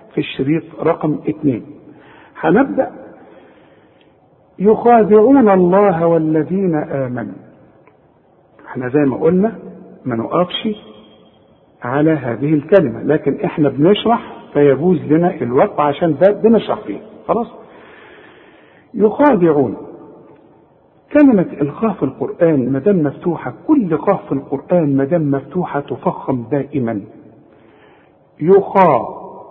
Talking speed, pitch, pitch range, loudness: 95 wpm, 160 Hz, 140-205 Hz, -15 LUFS